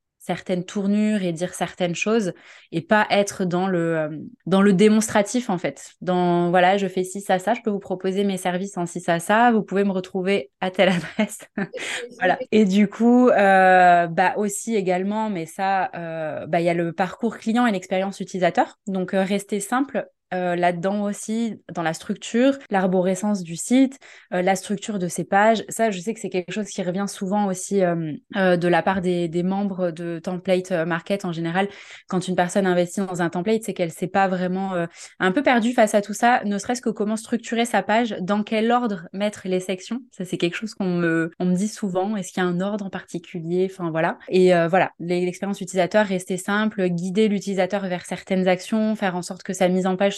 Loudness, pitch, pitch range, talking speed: -22 LUFS, 190 Hz, 180-210 Hz, 210 wpm